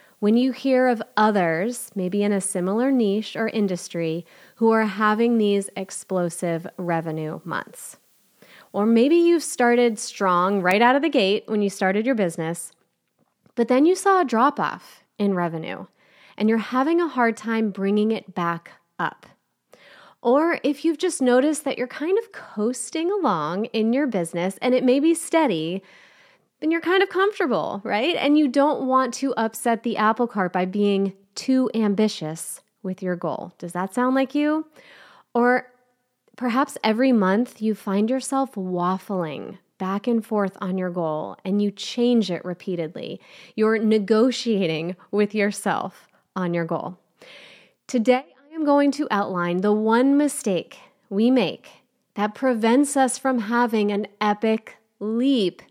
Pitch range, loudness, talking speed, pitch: 190-255 Hz, -22 LUFS, 155 wpm, 220 Hz